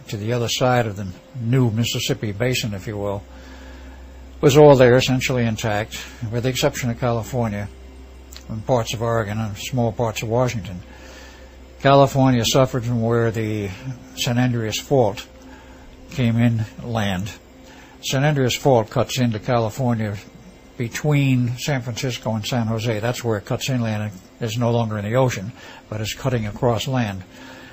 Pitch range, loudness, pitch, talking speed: 105-125 Hz, -20 LUFS, 115 Hz, 155 wpm